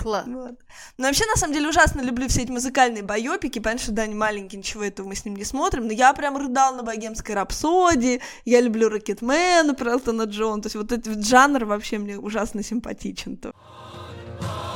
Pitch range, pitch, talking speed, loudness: 210-260 Hz, 230 Hz, 185 wpm, -22 LUFS